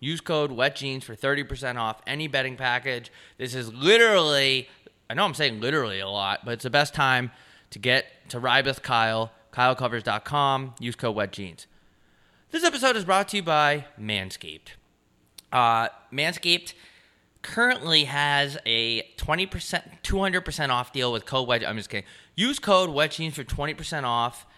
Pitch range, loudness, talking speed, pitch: 120-155 Hz, -24 LUFS, 165 wpm, 135 Hz